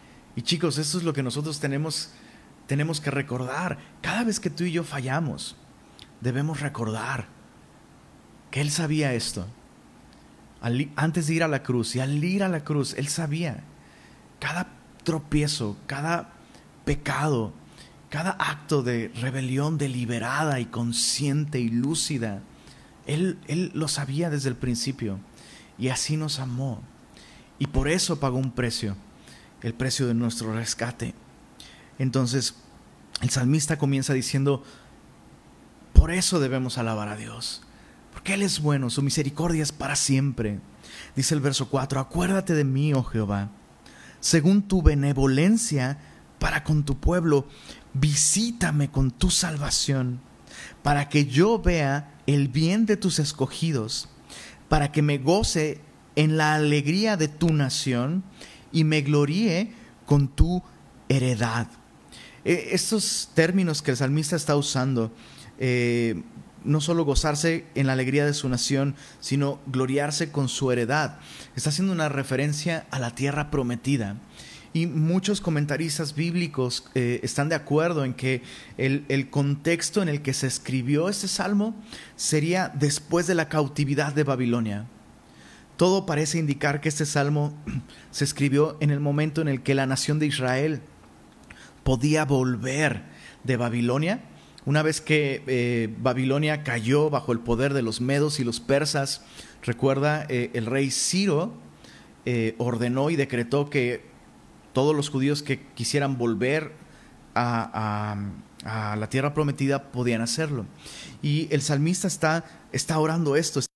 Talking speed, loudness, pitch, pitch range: 140 wpm, -25 LUFS, 140 Hz, 125-155 Hz